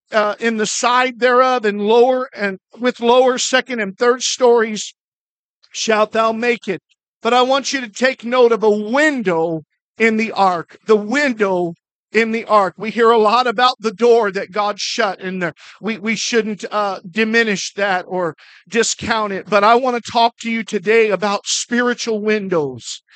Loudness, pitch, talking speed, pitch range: -16 LUFS, 225 Hz, 175 wpm, 205-240 Hz